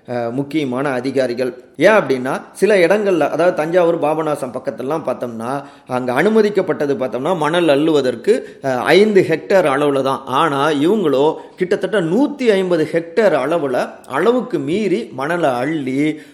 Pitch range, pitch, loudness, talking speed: 130-180 Hz, 150 Hz, -16 LUFS, 115 wpm